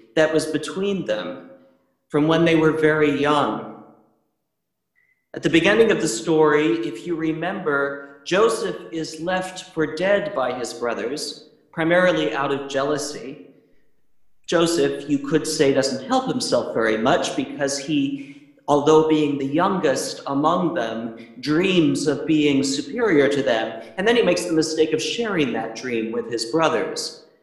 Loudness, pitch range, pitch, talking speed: -21 LUFS, 140-170 Hz, 155 Hz, 145 wpm